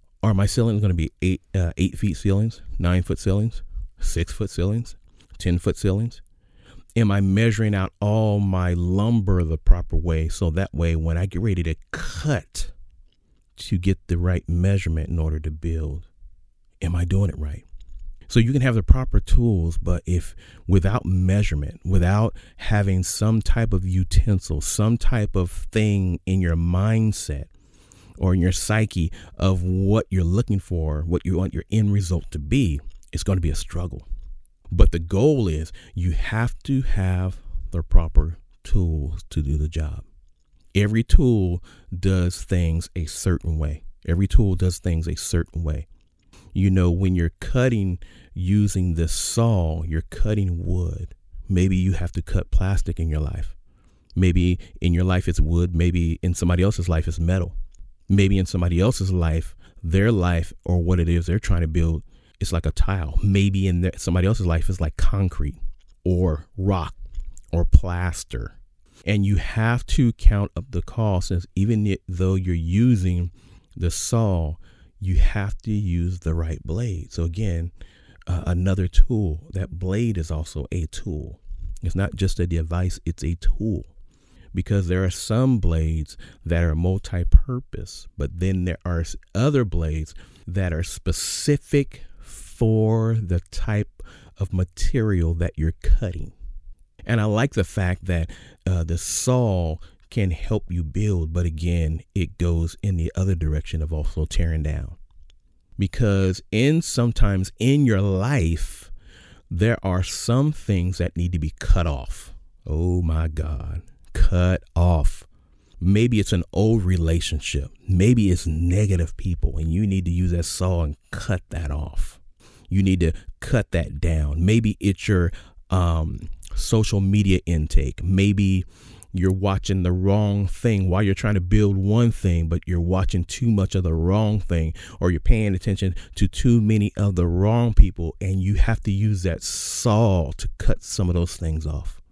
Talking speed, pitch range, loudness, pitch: 165 wpm, 85-100 Hz, -23 LUFS, 90 Hz